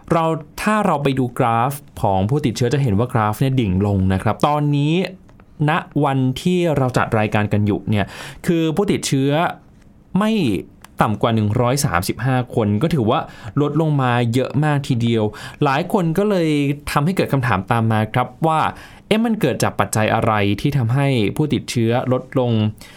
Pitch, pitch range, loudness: 130 Hz, 110-150 Hz, -19 LUFS